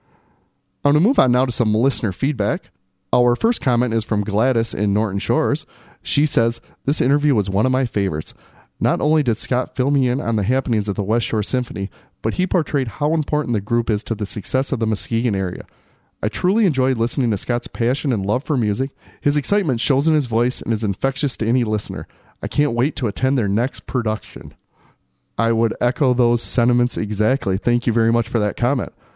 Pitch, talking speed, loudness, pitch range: 120 Hz, 210 wpm, -20 LUFS, 110-135 Hz